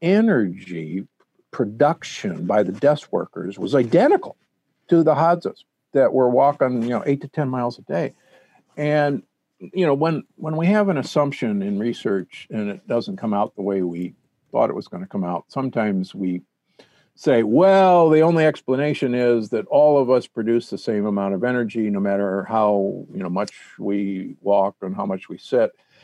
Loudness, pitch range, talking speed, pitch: -21 LUFS, 100-155 Hz, 180 wpm, 130 Hz